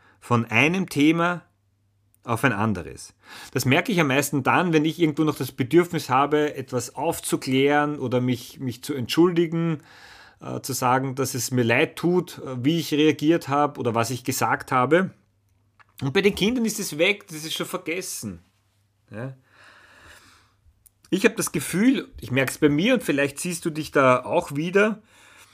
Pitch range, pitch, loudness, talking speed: 125-165 Hz, 145 Hz, -23 LUFS, 170 wpm